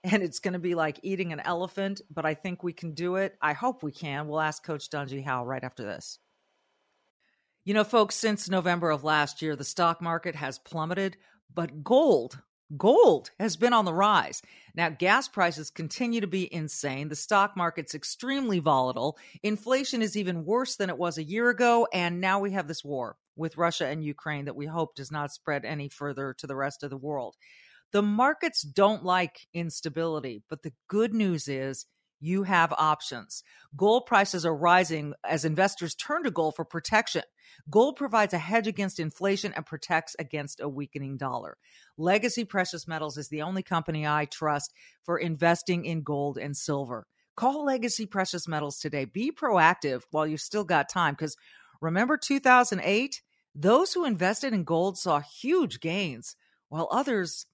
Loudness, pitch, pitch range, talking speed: -28 LUFS, 170 Hz, 150-205 Hz, 175 wpm